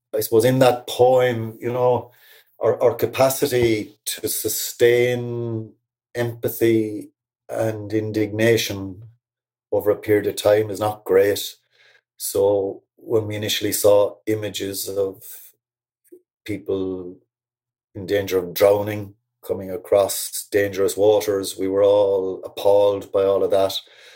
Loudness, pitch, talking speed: -20 LUFS, 120 Hz, 115 wpm